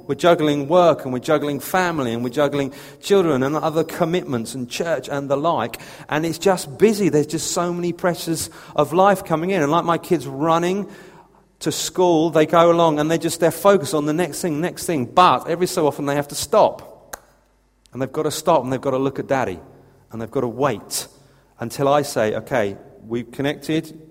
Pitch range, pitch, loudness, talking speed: 140-175 Hz, 155 Hz, -20 LUFS, 210 wpm